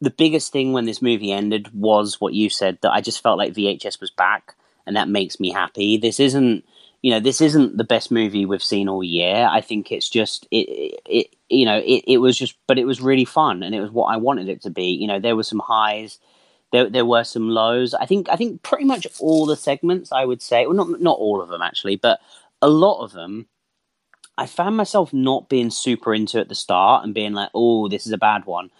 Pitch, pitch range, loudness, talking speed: 120 Hz, 105-140 Hz, -19 LUFS, 245 wpm